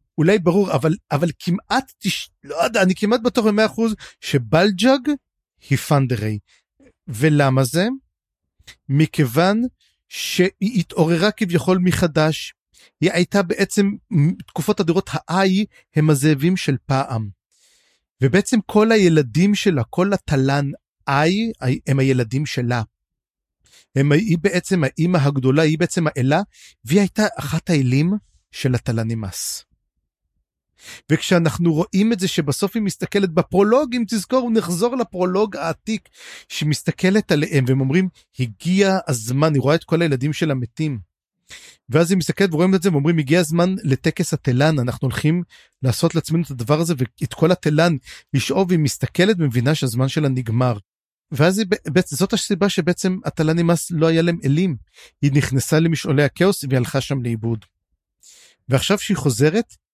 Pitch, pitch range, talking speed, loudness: 165 Hz, 135-190 Hz, 135 wpm, -19 LUFS